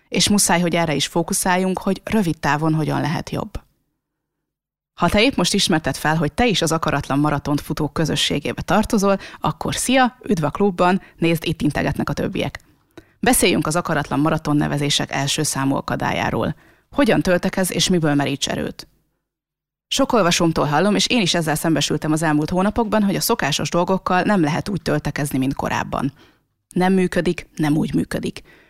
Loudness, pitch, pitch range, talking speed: -19 LUFS, 165 Hz, 150-190 Hz, 160 wpm